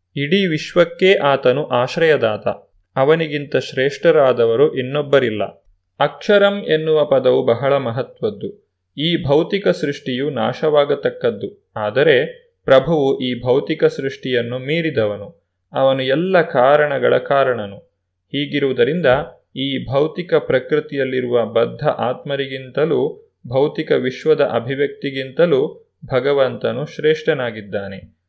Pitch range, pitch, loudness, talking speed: 125-170 Hz, 140 Hz, -17 LUFS, 80 wpm